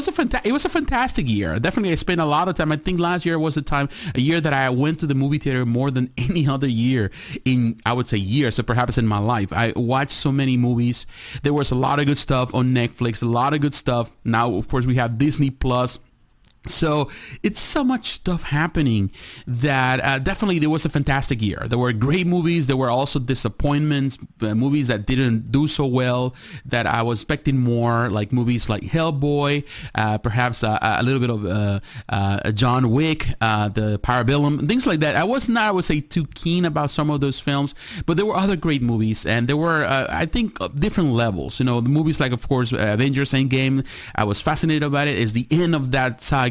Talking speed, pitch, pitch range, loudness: 225 wpm, 135 Hz, 120-150 Hz, -20 LUFS